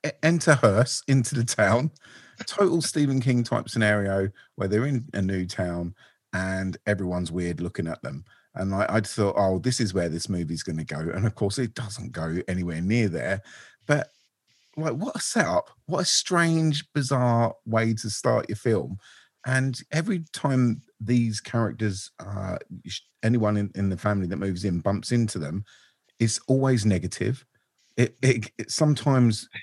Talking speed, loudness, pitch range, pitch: 165 wpm, -25 LUFS, 95-130 Hz, 110 Hz